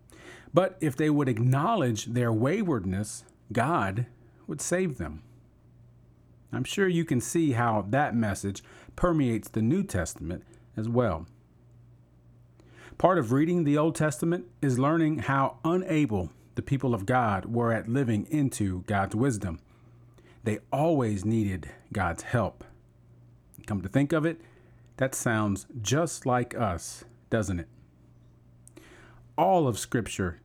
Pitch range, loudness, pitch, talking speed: 105-140 Hz, -28 LUFS, 120 Hz, 130 wpm